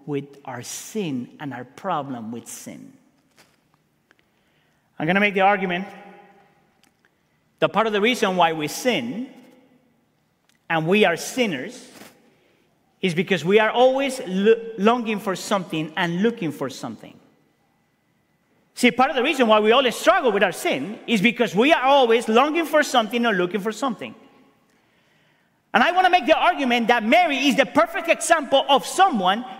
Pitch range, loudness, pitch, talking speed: 195-260 Hz, -20 LUFS, 230 Hz, 155 wpm